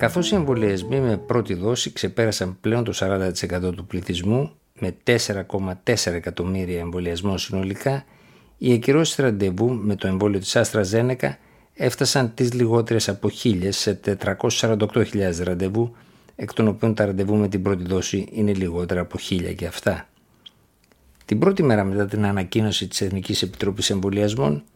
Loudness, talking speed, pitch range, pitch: -22 LUFS, 145 wpm, 95-115 Hz, 100 Hz